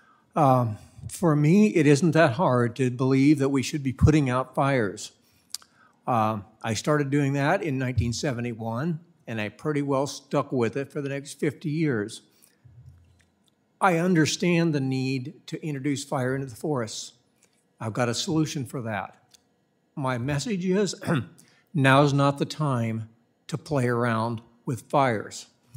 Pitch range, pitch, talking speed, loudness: 120-155 Hz, 135 Hz, 150 wpm, -25 LUFS